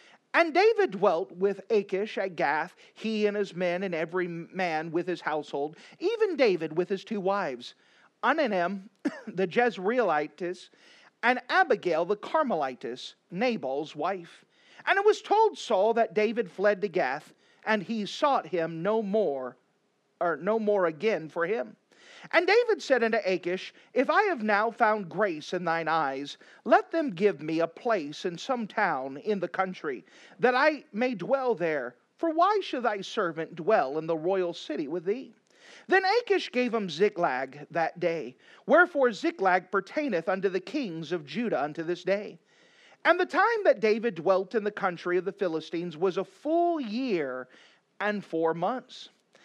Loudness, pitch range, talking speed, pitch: -28 LUFS, 175-265 Hz, 165 wpm, 205 Hz